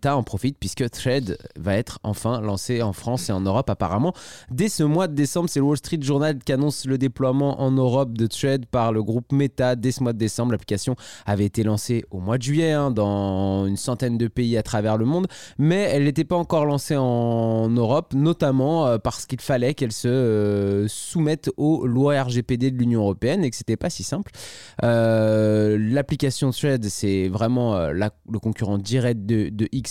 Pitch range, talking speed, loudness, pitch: 110-140 Hz, 200 wpm, -22 LUFS, 125 Hz